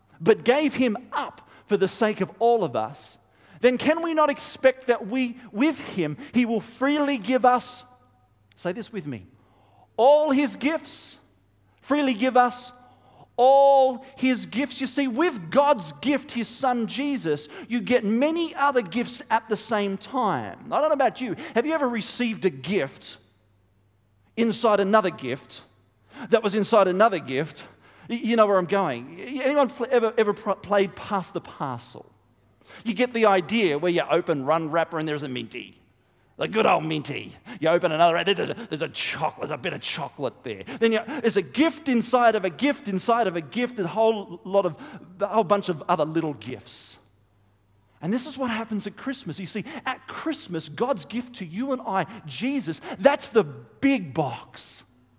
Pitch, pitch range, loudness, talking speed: 215 Hz, 160-255 Hz, -24 LUFS, 175 wpm